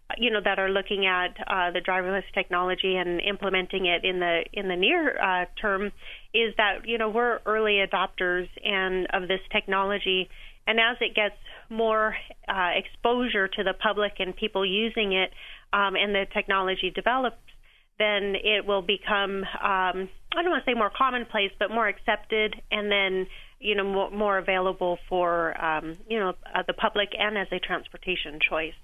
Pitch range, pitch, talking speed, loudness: 185-215 Hz, 195 Hz, 175 wpm, -26 LUFS